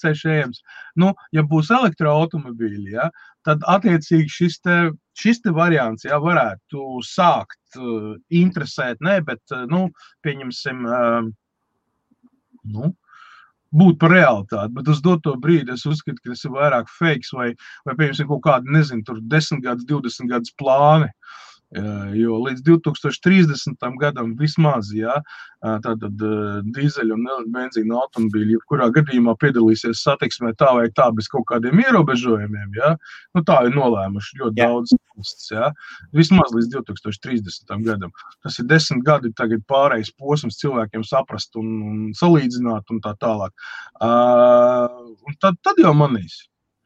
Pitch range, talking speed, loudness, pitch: 115-155 Hz, 130 wpm, -18 LUFS, 130 Hz